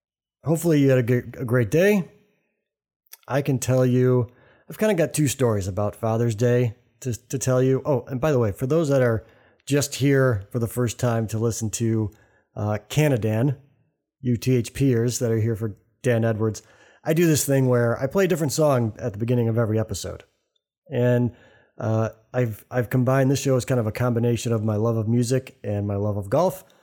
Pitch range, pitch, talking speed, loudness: 115-135 Hz, 125 Hz, 205 wpm, -23 LUFS